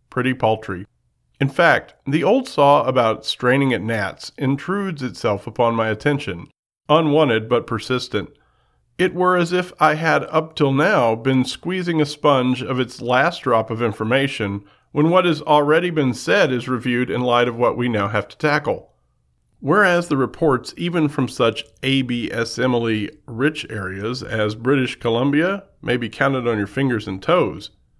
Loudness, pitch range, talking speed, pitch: -19 LUFS, 115-150 Hz, 160 wpm, 130 Hz